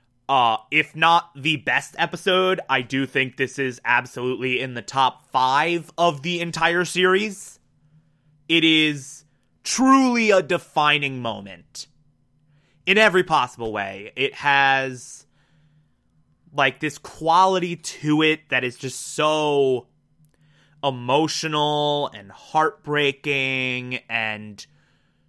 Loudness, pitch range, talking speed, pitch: -21 LUFS, 130-160 Hz, 105 wpm, 150 Hz